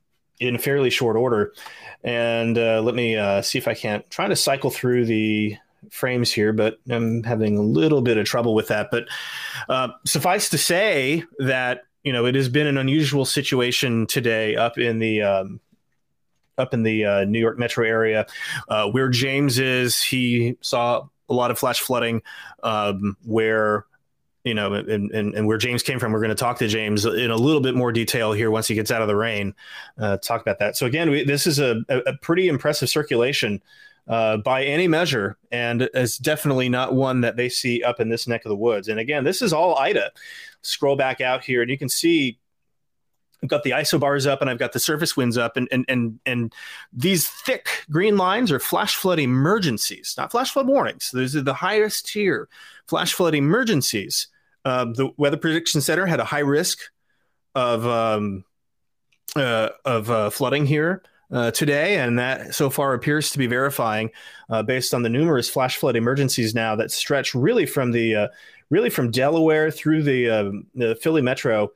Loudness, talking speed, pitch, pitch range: -21 LUFS, 195 wpm, 125 Hz, 115-145 Hz